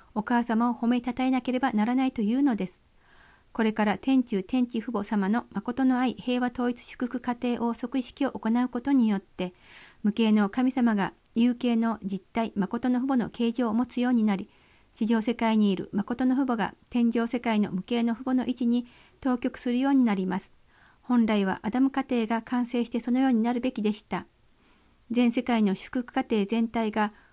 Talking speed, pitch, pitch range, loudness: 355 characters per minute, 240 Hz, 220-250 Hz, -27 LUFS